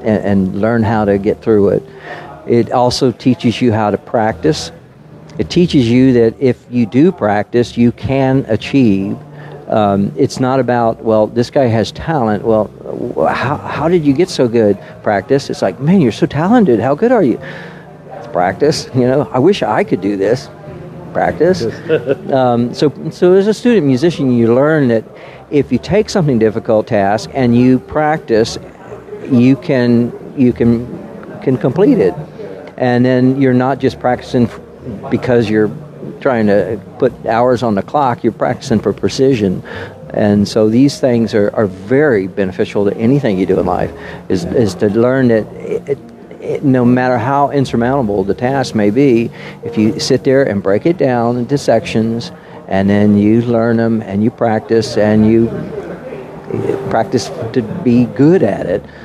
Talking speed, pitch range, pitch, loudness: 170 wpm, 110-140 Hz, 120 Hz, -13 LUFS